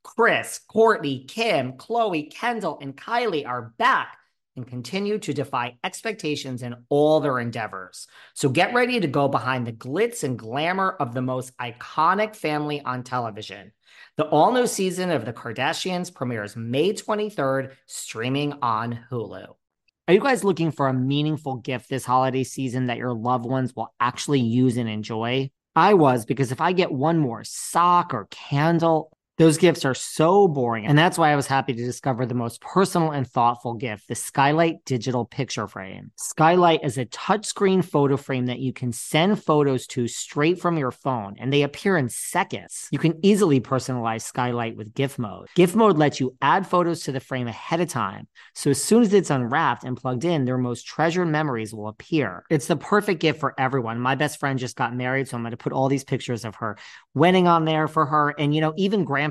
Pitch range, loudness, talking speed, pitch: 125-165 Hz, -23 LUFS, 190 wpm, 135 Hz